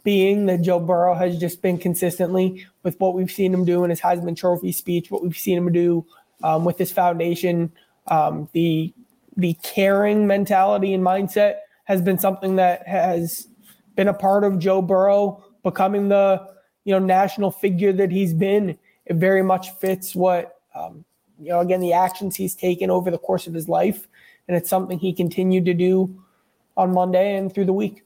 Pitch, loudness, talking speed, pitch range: 185 Hz, -20 LUFS, 185 wpm, 175-195 Hz